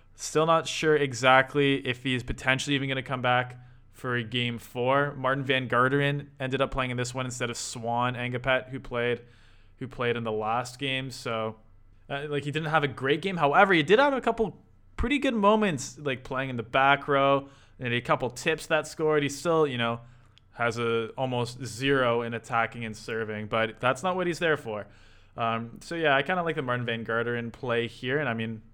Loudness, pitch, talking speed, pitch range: -27 LUFS, 130 Hz, 215 wpm, 115-140 Hz